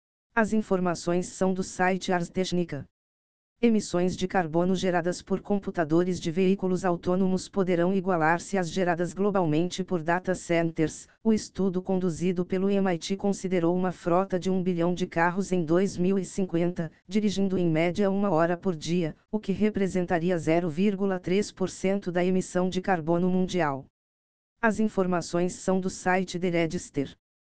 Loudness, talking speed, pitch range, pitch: -27 LUFS, 135 wpm, 175-190 Hz, 180 Hz